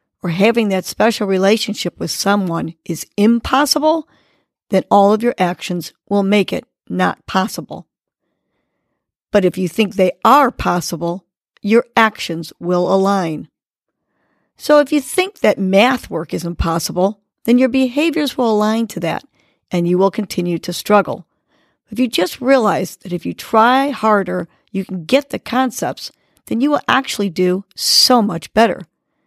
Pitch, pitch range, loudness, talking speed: 205 Hz, 180-240 Hz, -16 LUFS, 150 wpm